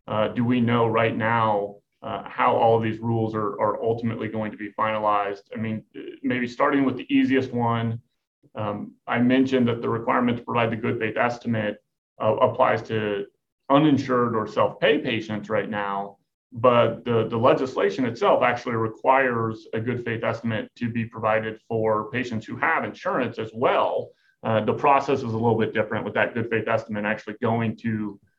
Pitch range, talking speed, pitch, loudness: 110-125 Hz, 180 wpm, 115 Hz, -24 LUFS